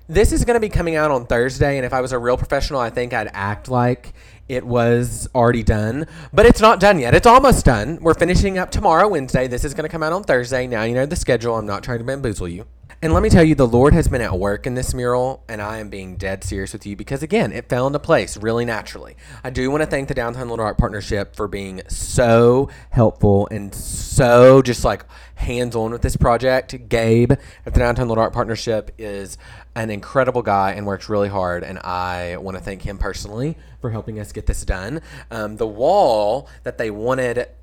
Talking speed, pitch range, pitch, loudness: 230 wpm, 105-130 Hz, 120 Hz, -18 LUFS